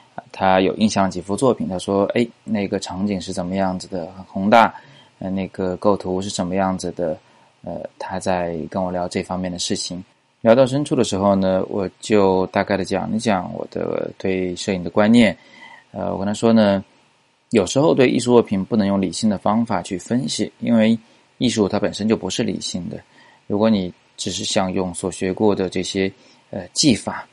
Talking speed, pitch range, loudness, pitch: 270 characters per minute, 95-105 Hz, -20 LUFS, 95 Hz